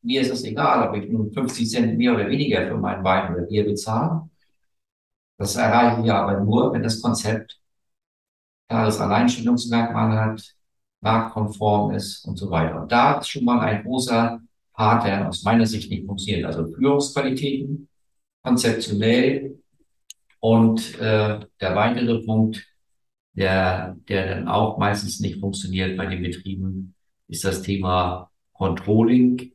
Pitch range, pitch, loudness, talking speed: 95-120 Hz, 110 Hz, -22 LUFS, 140 wpm